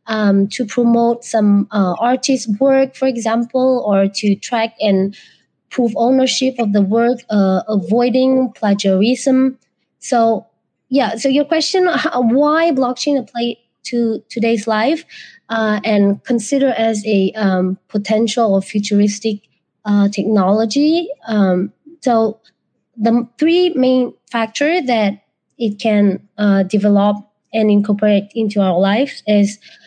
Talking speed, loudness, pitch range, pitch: 125 wpm, -15 LUFS, 205-255 Hz, 225 Hz